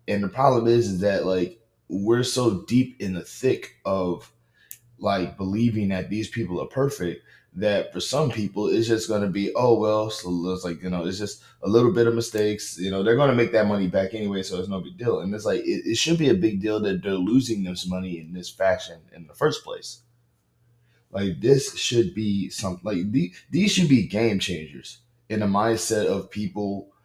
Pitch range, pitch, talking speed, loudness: 95-120 Hz, 105 Hz, 215 wpm, -24 LUFS